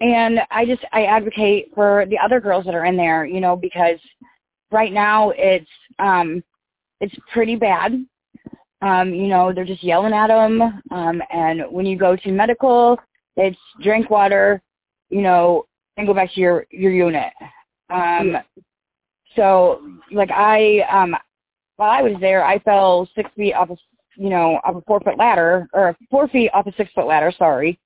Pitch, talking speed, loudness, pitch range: 195 Hz, 175 wpm, -17 LUFS, 180-215 Hz